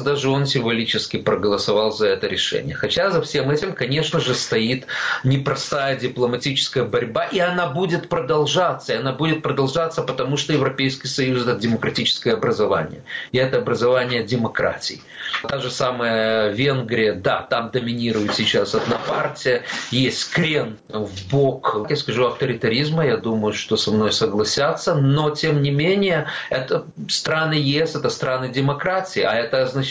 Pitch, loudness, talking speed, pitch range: 135 Hz, -20 LUFS, 145 wpm, 120-150 Hz